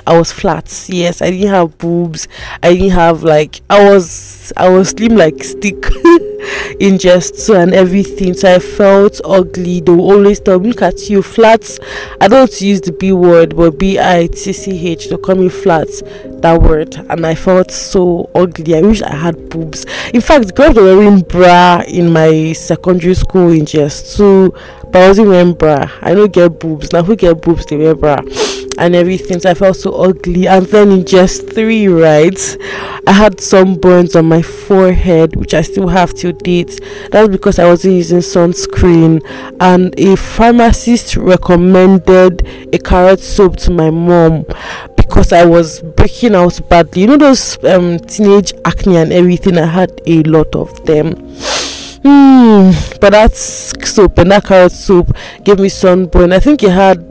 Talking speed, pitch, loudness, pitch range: 180 wpm, 185 Hz, -8 LUFS, 170-200 Hz